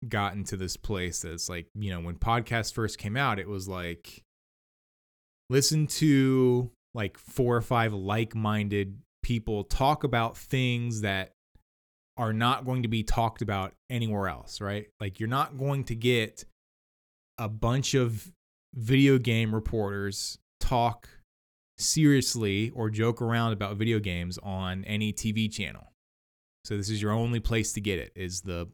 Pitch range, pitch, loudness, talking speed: 95-120 Hz, 110 Hz, -29 LUFS, 155 wpm